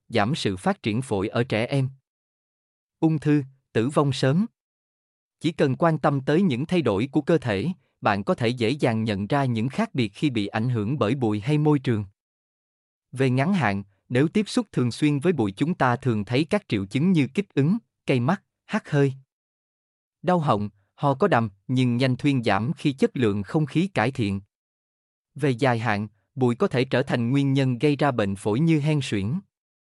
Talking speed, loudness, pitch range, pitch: 205 wpm, -24 LUFS, 110-155 Hz, 130 Hz